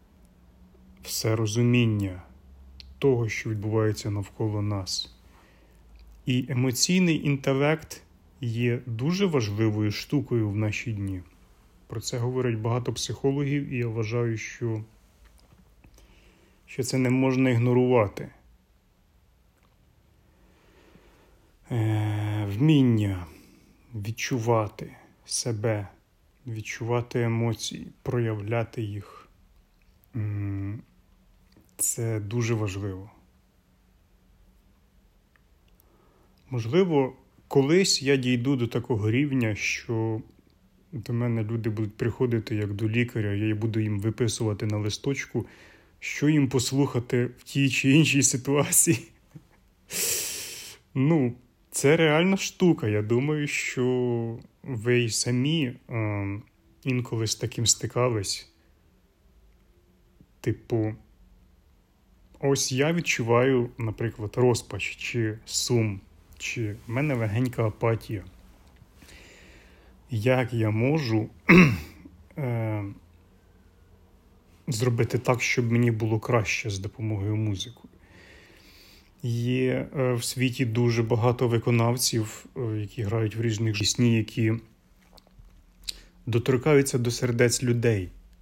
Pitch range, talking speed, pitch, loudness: 95-125 Hz, 85 wpm, 115 Hz, -26 LUFS